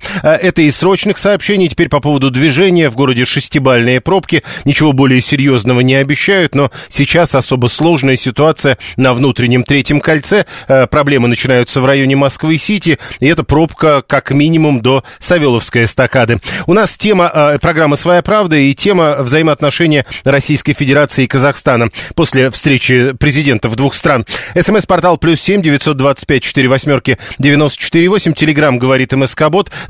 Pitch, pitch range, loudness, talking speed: 145 Hz, 130-160 Hz, -10 LUFS, 145 wpm